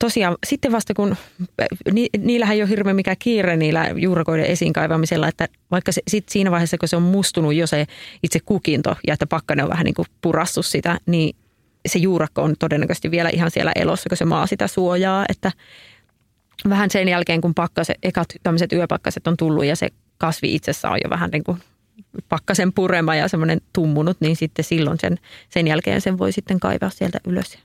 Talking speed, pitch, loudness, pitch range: 190 wpm, 170 Hz, -20 LUFS, 160-190 Hz